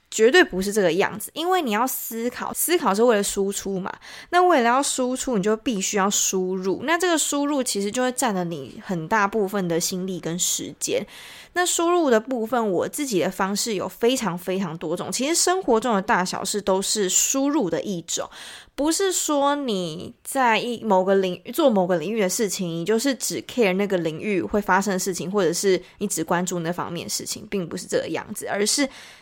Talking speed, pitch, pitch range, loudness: 310 characters per minute, 210 Hz, 185-260 Hz, -22 LUFS